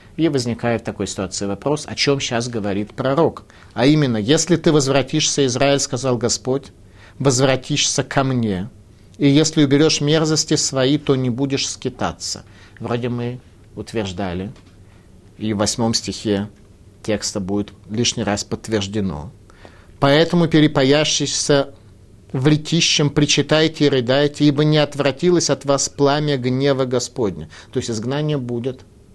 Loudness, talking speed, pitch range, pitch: -18 LUFS, 130 wpm, 105-145 Hz, 125 Hz